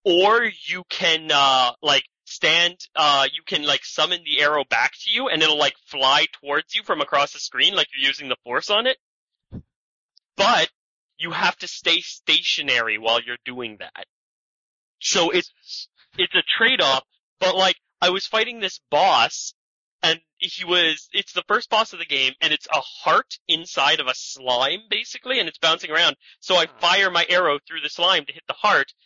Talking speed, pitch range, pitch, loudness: 185 wpm, 145-190 Hz, 175 Hz, -20 LUFS